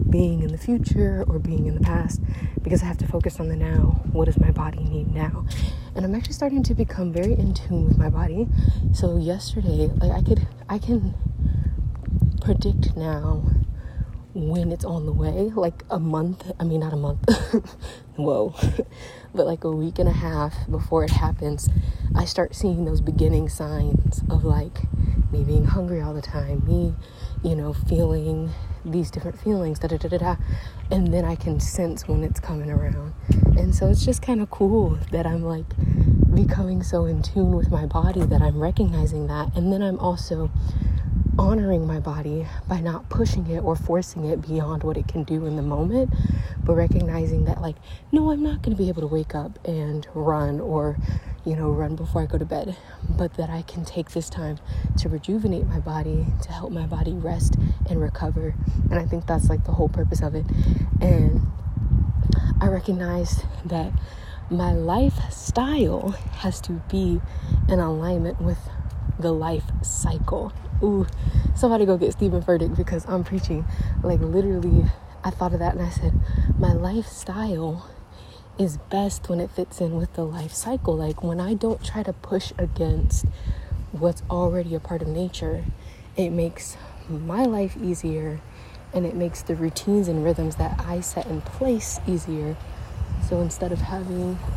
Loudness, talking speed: -24 LUFS, 180 wpm